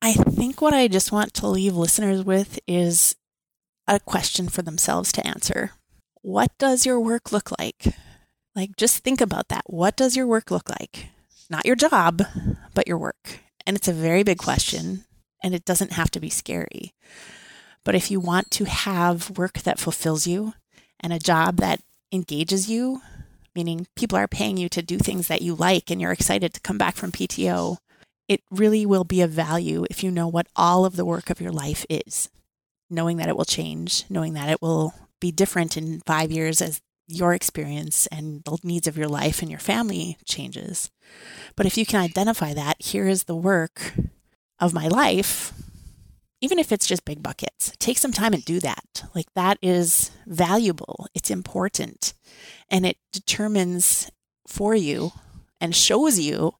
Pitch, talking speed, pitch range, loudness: 180 Hz, 180 wpm, 170-200 Hz, -23 LUFS